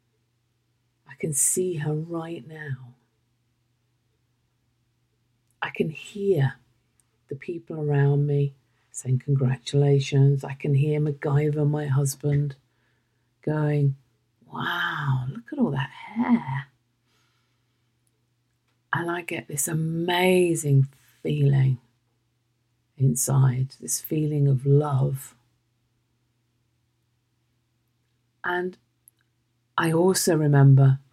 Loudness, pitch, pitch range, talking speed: -24 LUFS, 130 Hz, 120-145 Hz, 85 wpm